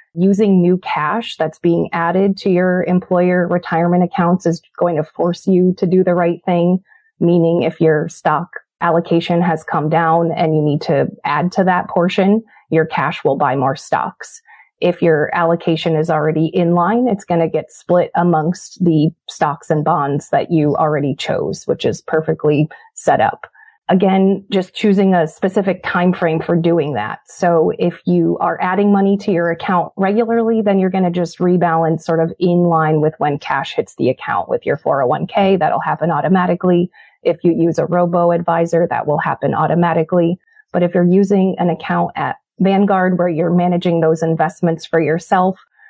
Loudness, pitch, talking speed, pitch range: -16 LUFS, 175 Hz, 180 wpm, 165-185 Hz